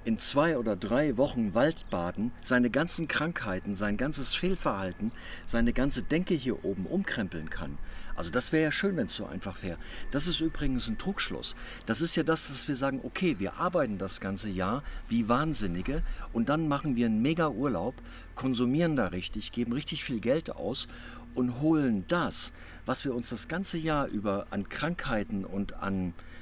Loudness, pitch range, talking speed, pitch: -31 LUFS, 95-150 Hz, 175 wpm, 120 Hz